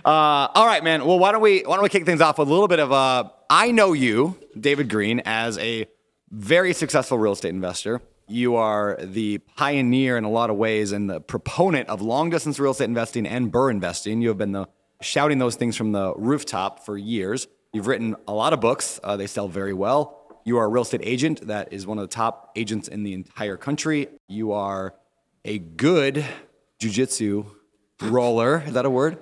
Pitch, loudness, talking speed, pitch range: 115 Hz, -22 LUFS, 215 wpm, 105-145 Hz